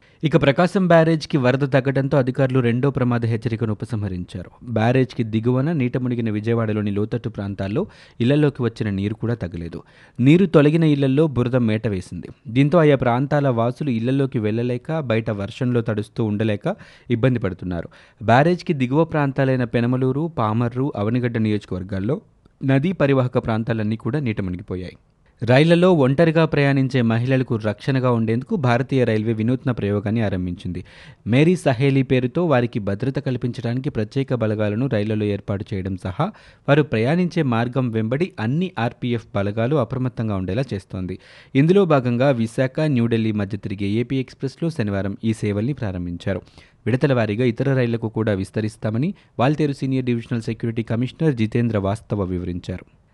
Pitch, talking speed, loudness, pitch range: 120 Hz, 125 wpm, -21 LUFS, 110-135 Hz